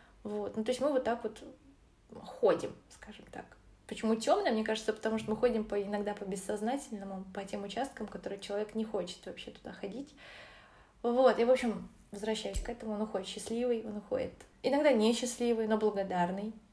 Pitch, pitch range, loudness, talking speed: 220 Hz, 205-240 Hz, -34 LUFS, 170 wpm